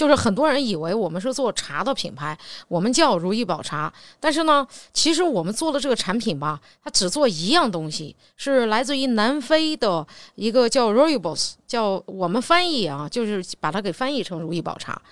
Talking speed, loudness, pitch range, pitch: 305 characters per minute, -22 LUFS, 180-280 Hz, 235 Hz